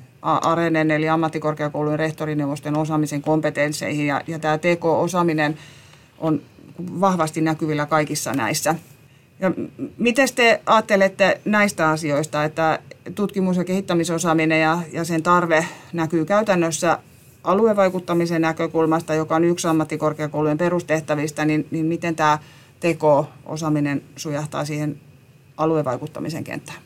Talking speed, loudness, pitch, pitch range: 105 wpm, -21 LUFS, 155 Hz, 150-170 Hz